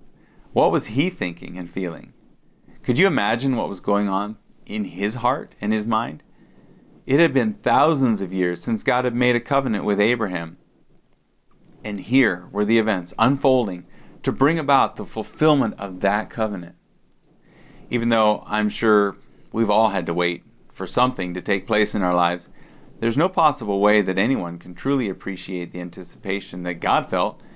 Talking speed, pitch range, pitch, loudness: 170 wpm, 90-115 Hz, 105 Hz, -21 LUFS